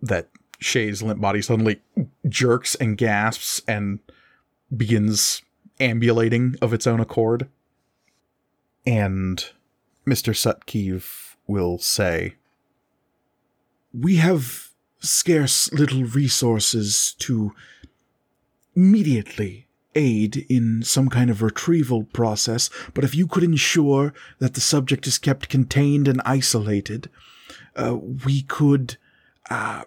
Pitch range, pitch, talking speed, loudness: 110-140 Hz, 125 Hz, 100 wpm, -21 LUFS